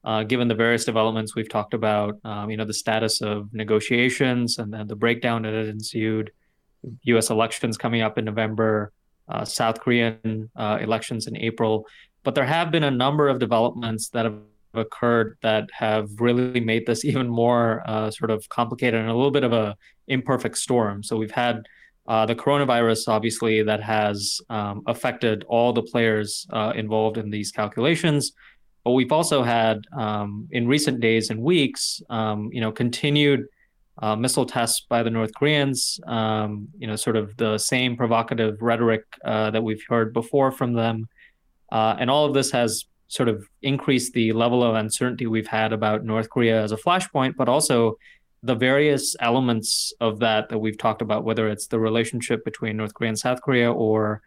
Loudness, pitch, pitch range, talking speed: -23 LUFS, 115 Hz, 110-120 Hz, 180 wpm